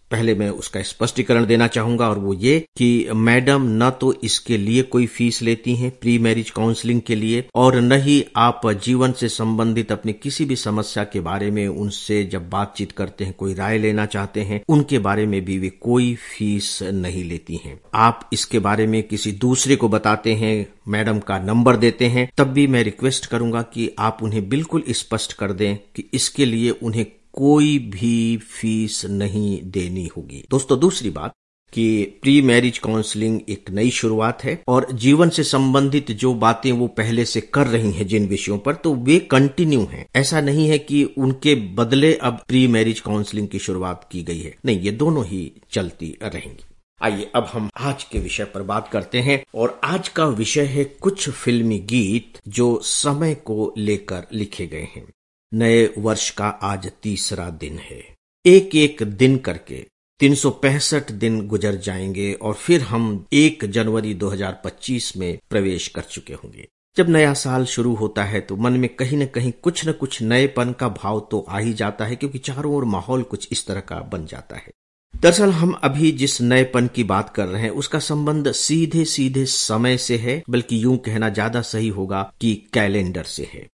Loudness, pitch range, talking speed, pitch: -19 LUFS, 105-130 Hz, 185 wpm, 115 Hz